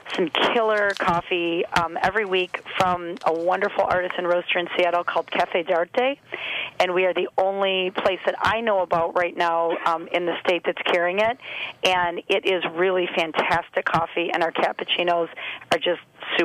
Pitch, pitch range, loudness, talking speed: 180 Hz, 175-190 Hz, -23 LUFS, 170 wpm